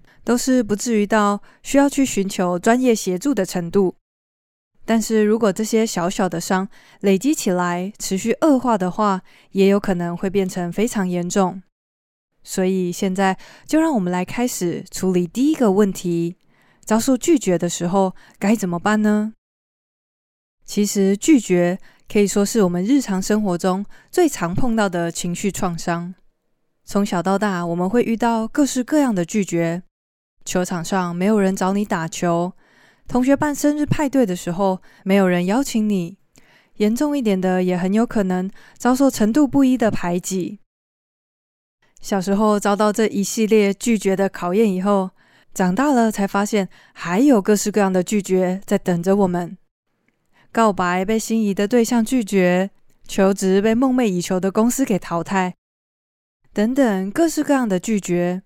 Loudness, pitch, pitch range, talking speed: -19 LUFS, 200 Hz, 180-225 Hz, 240 characters per minute